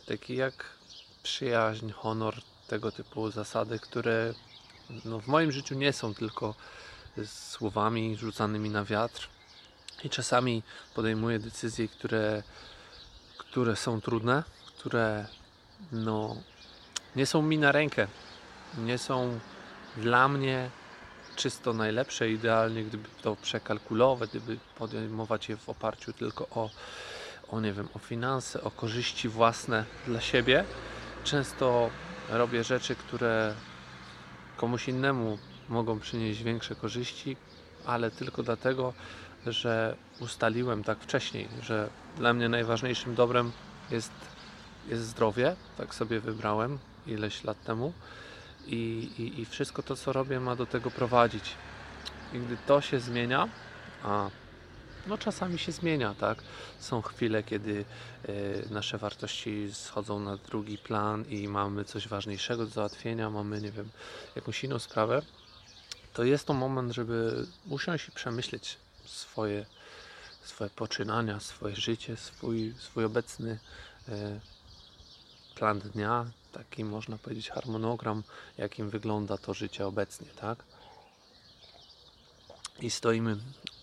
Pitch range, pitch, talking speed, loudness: 105-120 Hz, 115 Hz, 120 wpm, -32 LUFS